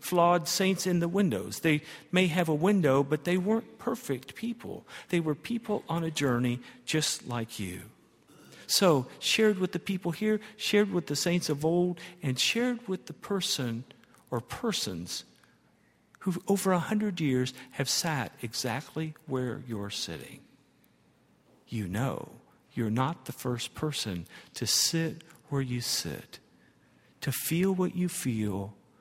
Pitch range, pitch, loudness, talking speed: 130-185 Hz, 160 Hz, -30 LUFS, 145 wpm